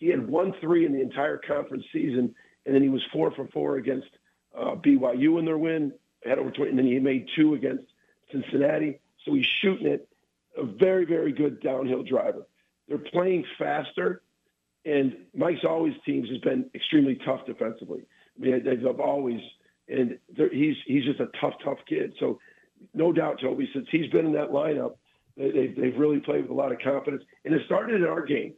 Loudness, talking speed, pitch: -26 LUFS, 190 wpm, 160 Hz